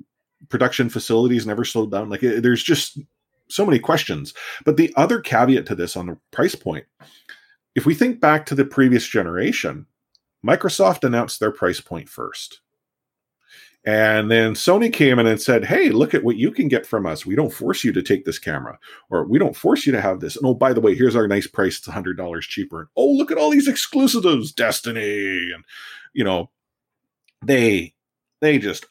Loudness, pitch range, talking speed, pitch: -19 LUFS, 110-155 Hz, 195 wpm, 125 Hz